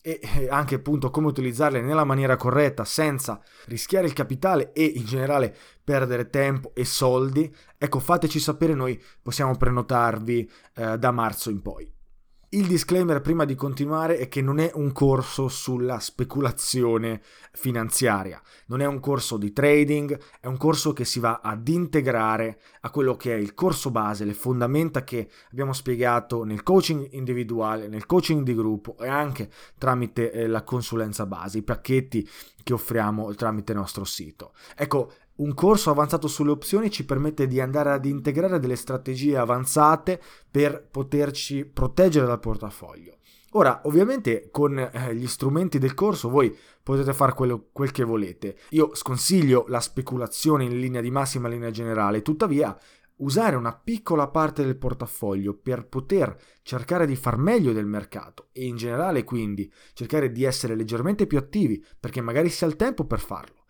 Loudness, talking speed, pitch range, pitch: -24 LUFS, 160 wpm, 115-150 Hz, 130 Hz